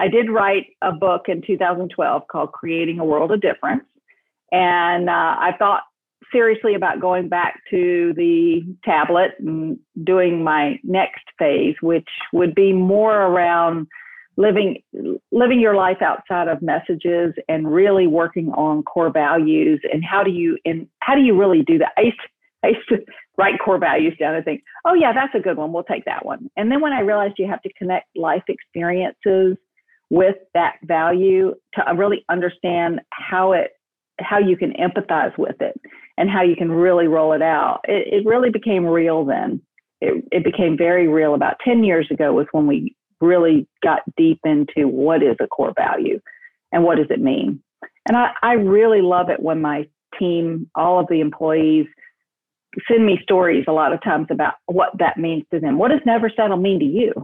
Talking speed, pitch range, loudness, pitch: 185 wpm, 165-225 Hz, -18 LUFS, 185 Hz